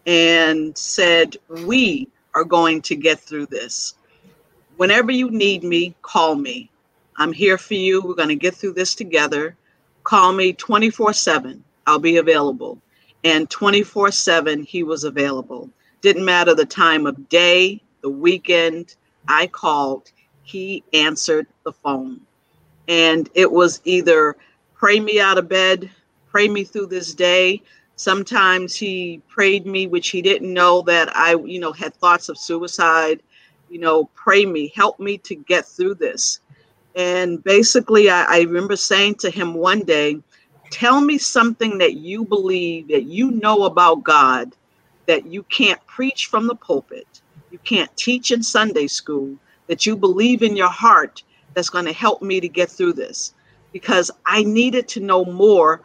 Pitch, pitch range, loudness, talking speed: 180 Hz, 165-205 Hz, -16 LUFS, 160 wpm